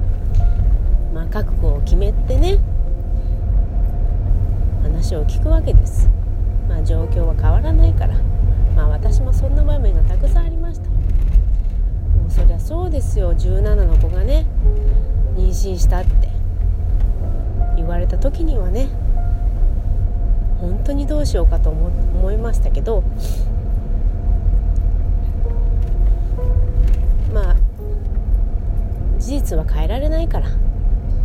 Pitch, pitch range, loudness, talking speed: 90 Hz, 85-95 Hz, -20 LUFS, 200 characters per minute